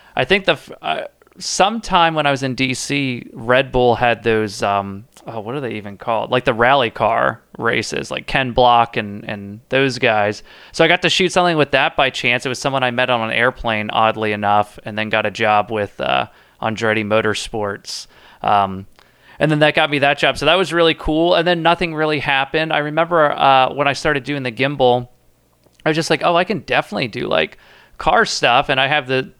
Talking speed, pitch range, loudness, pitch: 215 wpm, 110-150 Hz, -17 LUFS, 130 Hz